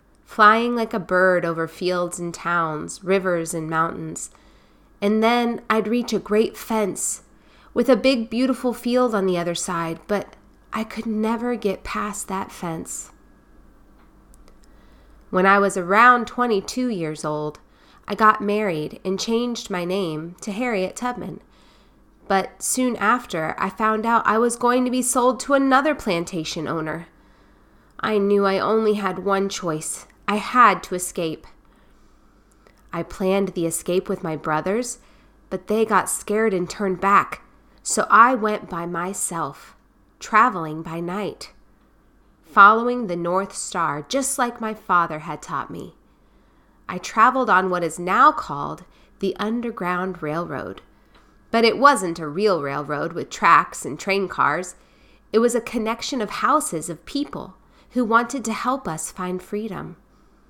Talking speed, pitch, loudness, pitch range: 150 wpm, 200 Hz, -21 LUFS, 175-230 Hz